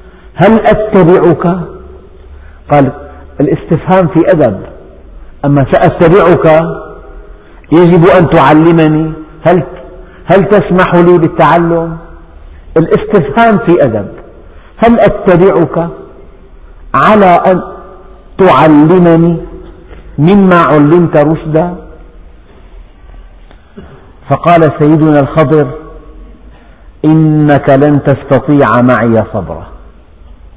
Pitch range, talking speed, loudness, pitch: 125-175 Hz, 70 wpm, -7 LUFS, 155 Hz